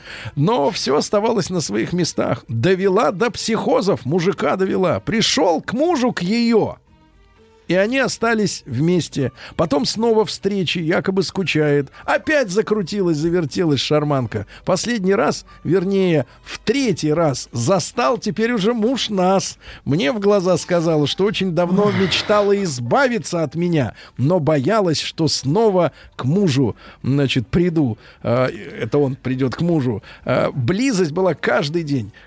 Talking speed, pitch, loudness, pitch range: 125 wpm, 180 Hz, -18 LUFS, 145-205 Hz